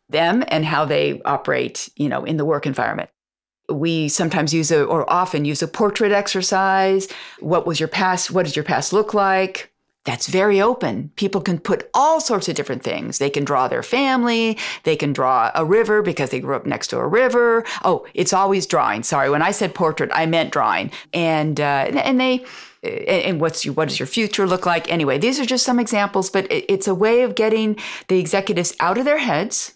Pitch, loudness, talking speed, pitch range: 190 Hz, -19 LUFS, 210 wpm, 160-220 Hz